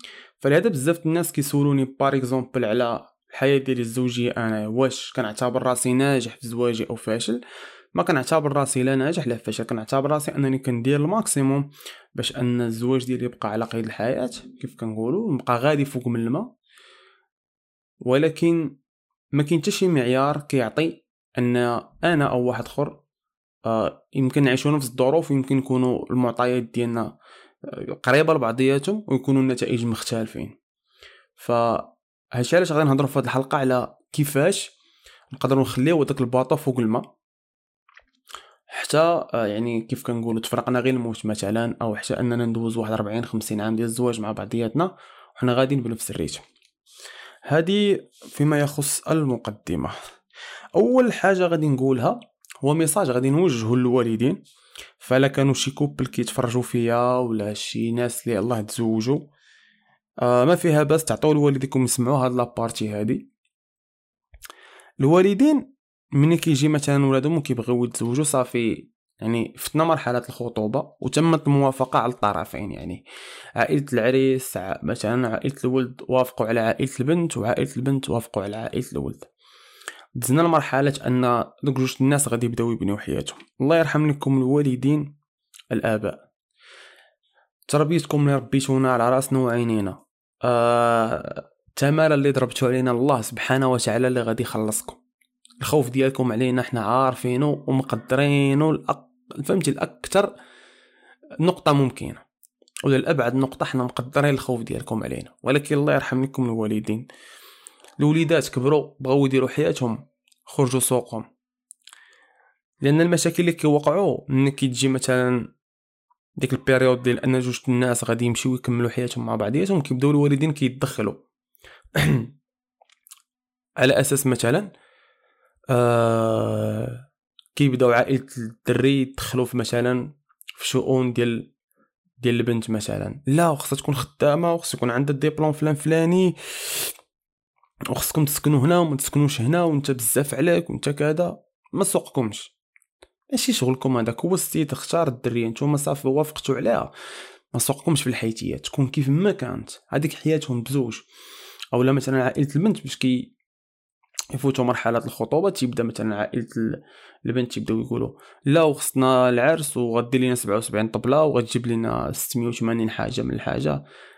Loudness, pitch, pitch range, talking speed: -22 LUFS, 130 Hz, 120-150 Hz, 130 wpm